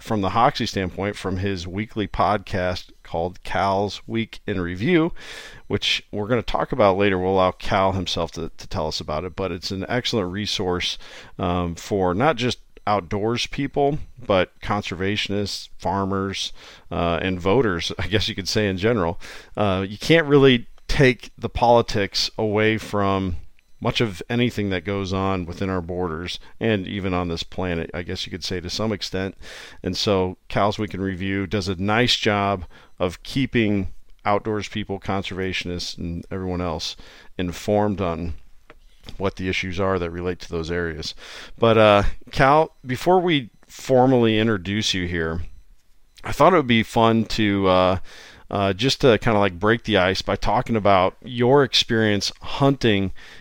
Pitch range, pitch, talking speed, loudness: 90-110 Hz, 100 Hz, 165 wpm, -22 LUFS